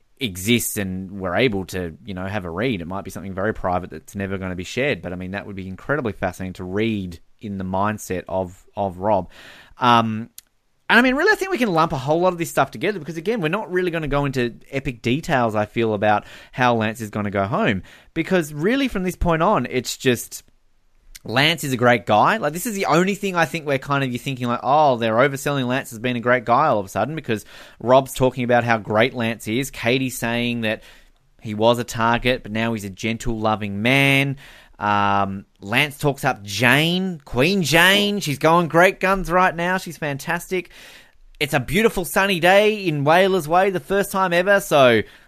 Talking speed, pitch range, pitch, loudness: 220 wpm, 105-165 Hz, 125 Hz, -20 LUFS